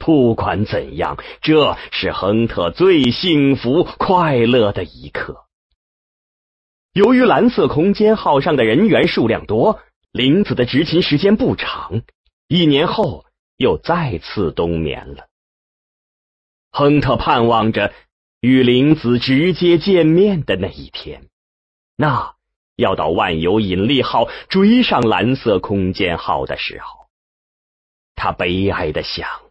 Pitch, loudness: 125 Hz, -15 LUFS